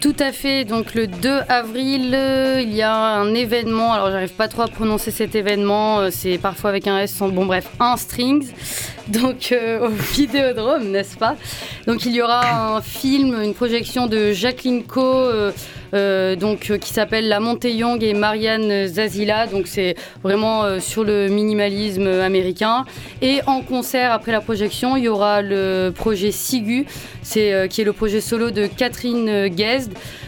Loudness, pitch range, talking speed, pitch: -19 LUFS, 205-245 Hz, 180 wpm, 220 Hz